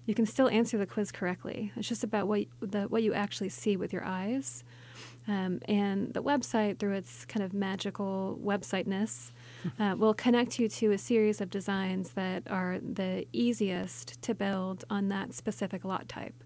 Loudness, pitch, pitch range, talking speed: -32 LUFS, 200 Hz, 190-220 Hz, 170 wpm